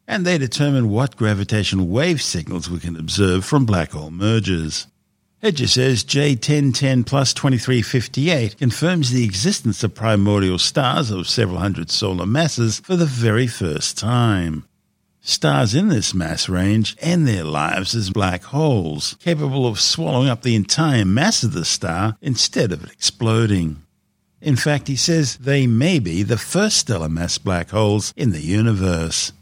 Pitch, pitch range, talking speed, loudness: 110 Hz, 95-135 Hz, 155 wpm, -18 LUFS